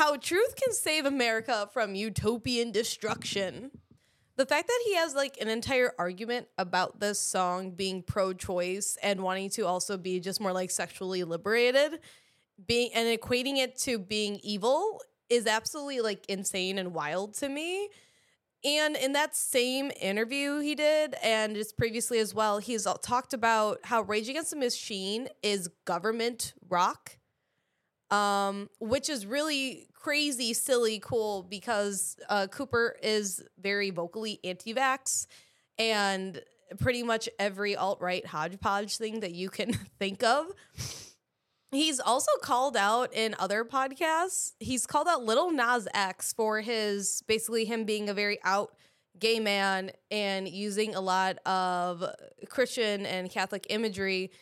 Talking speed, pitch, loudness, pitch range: 145 wpm, 220 Hz, -30 LUFS, 195-260 Hz